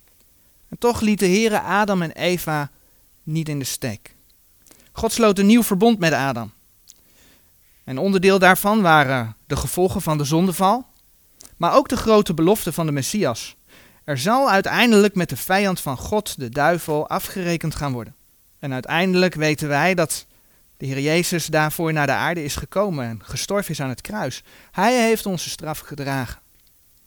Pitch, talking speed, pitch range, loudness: 160 Hz, 160 wpm, 135-195 Hz, -20 LUFS